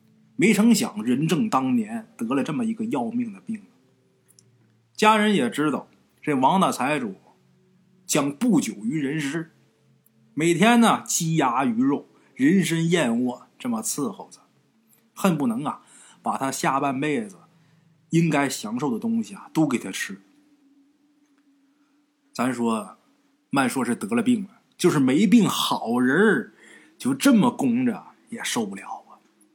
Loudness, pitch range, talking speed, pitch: -23 LUFS, 165-250 Hz, 195 characters per minute, 225 Hz